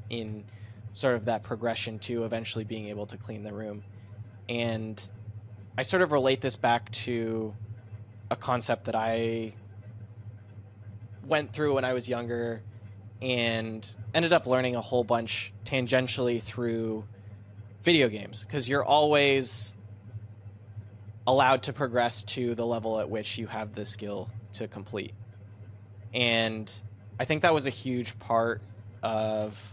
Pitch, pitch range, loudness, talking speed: 110 Hz, 105-120 Hz, -29 LUFS, 135 wpm